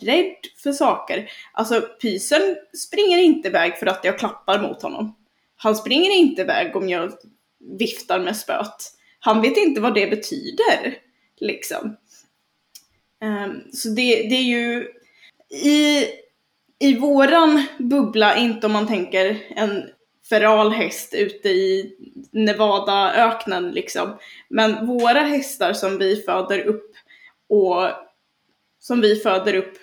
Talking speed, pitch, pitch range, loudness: 125 wpm, 235 Hz, 210-300 Hz, -19 LUFS